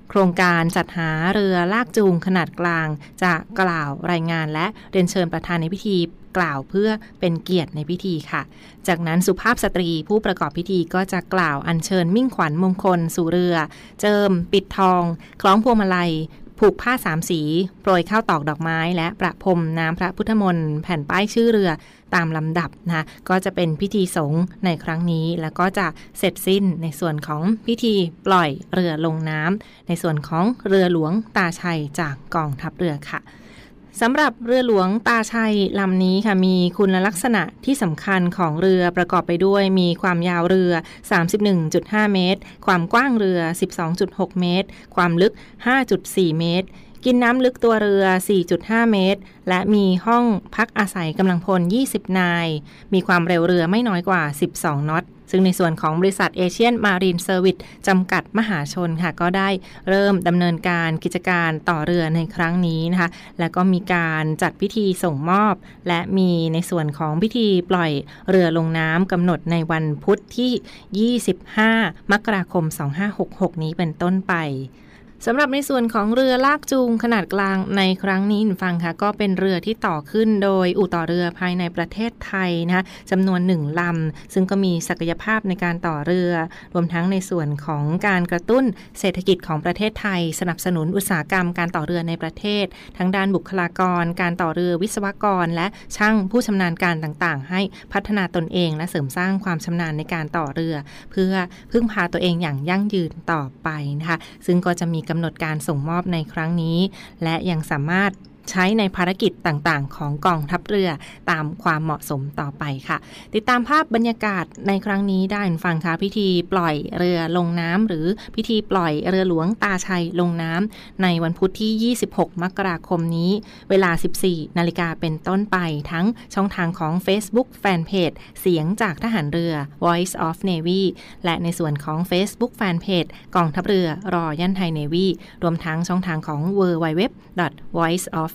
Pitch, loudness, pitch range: 180 Hz, -20 LUFS, 170-195 Hz